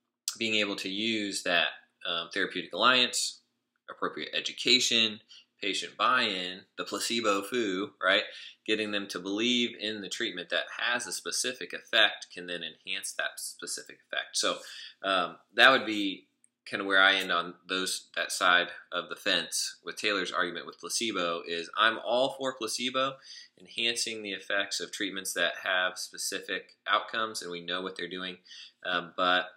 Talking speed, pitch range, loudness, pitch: 160 wpm, 90-110 Hz, -29 LUFS, 100 Hz